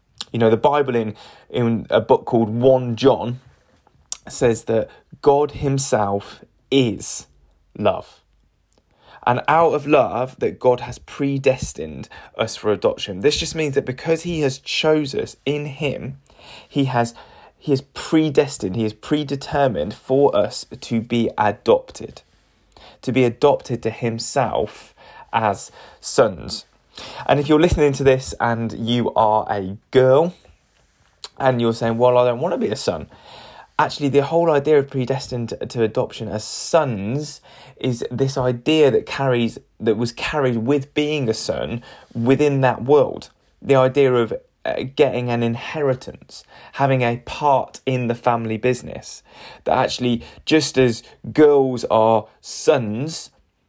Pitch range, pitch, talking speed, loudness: 115-140 Hz, 130 Hz, 140 wpm, -20 LUFS